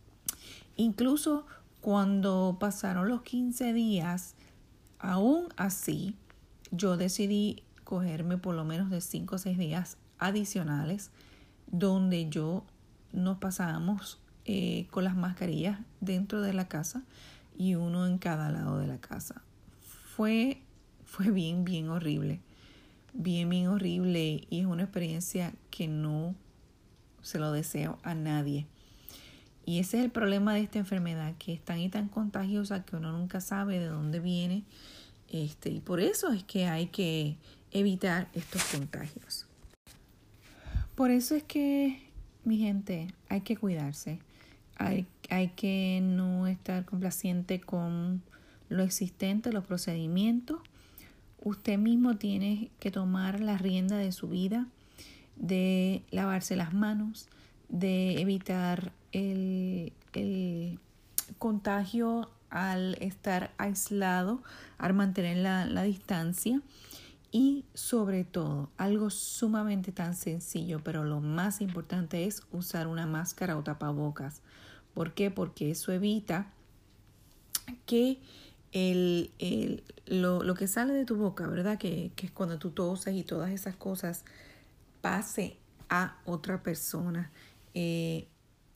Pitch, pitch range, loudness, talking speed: 185 Hz, 170-205 Hz, -33 LUFS, 125 wpm